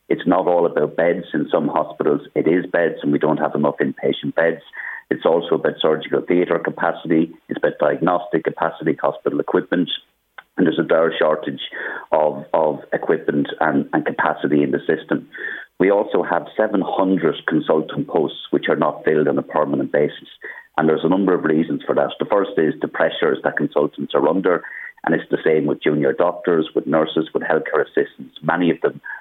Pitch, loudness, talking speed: 90 Hz, -19 LUFS, 185 wpm